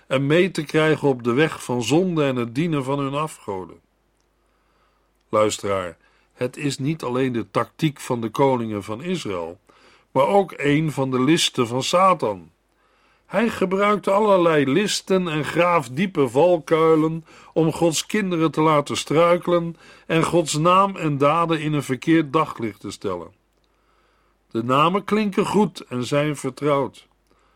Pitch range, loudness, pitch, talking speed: 135-170 Hz, -21 LUFS, 155 Hz, 145 wpm